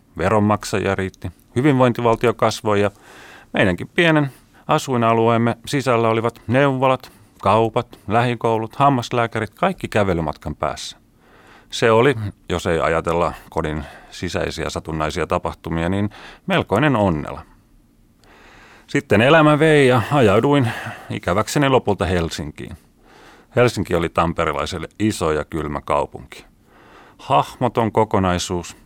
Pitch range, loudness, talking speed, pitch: 85-120 Hz, -19 LUFS, 95 wpm, 110 Hz